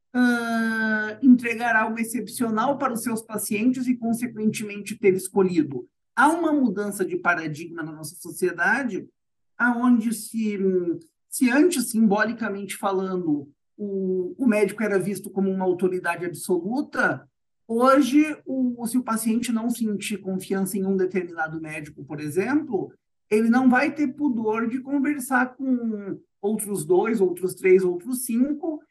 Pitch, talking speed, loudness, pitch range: 215 Hz, 130 wpm, -23 LUFS, 185-245 Hz